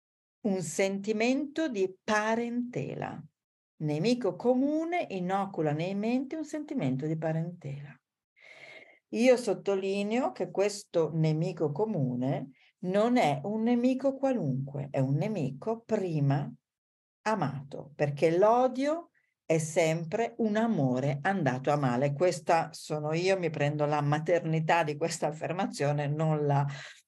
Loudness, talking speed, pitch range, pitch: -30 LUFS, 110 wpm, 150-220 Hz, 175 Hz